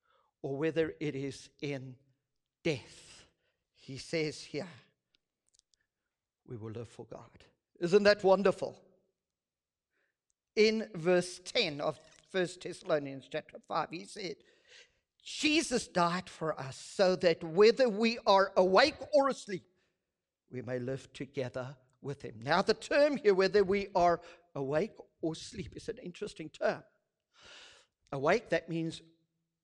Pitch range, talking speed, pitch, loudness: 140-205 Hz, 125 wpm, 170 Hz, -31 LUFS